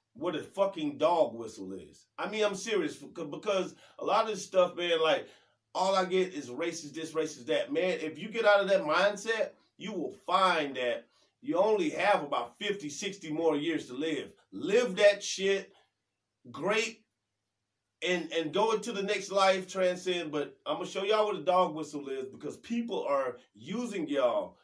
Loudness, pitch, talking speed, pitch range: -31 LUFS, 190 Hz, 185 wpm, 155-215 Hz